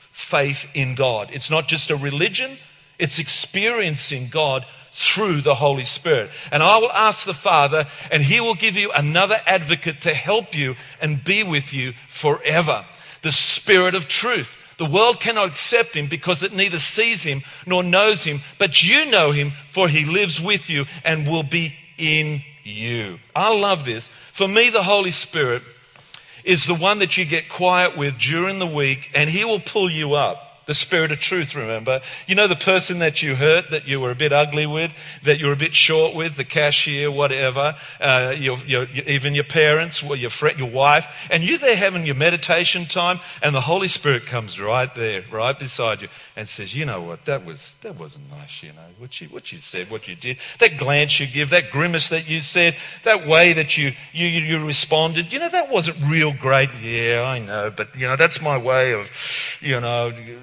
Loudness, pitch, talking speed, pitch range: -19 LUFS, 150 Hz, 205 wpm, 140-175 Hz